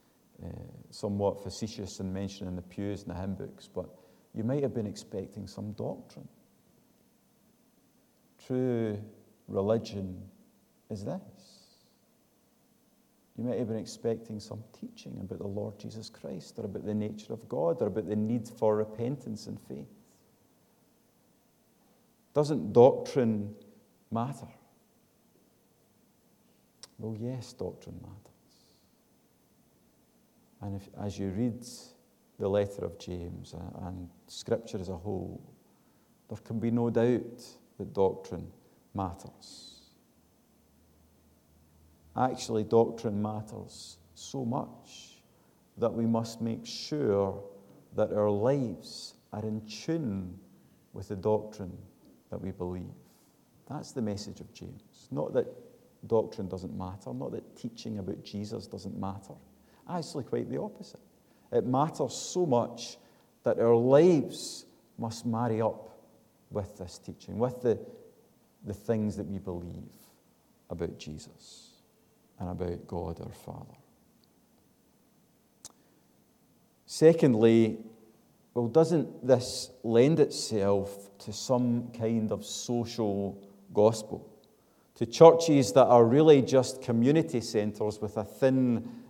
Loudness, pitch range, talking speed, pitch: -30 LUFS, 100-120 Hz, 115 wpm, 110 Hz